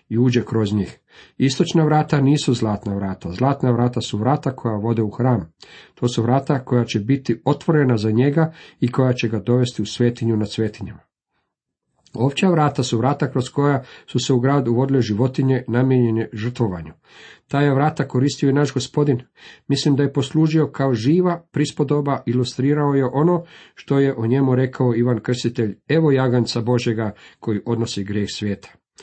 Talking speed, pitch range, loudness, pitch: 165 wpm, 115-140 Hz, -20 LUFS, 125 Hz